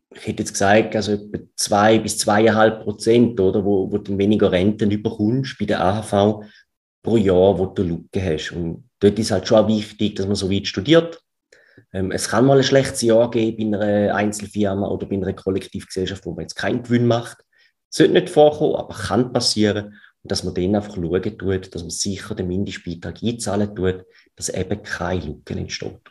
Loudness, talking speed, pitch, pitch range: -20 LUFS, 200 wpm, 105 Hz, 95-110 Hz